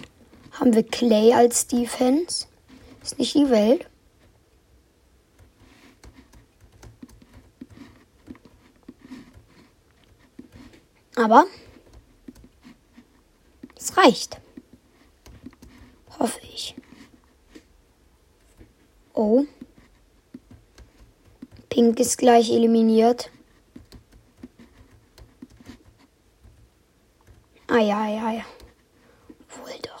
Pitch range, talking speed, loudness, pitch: 230-265 Hz, 55 wpm, -20 LUFS, 240 Hz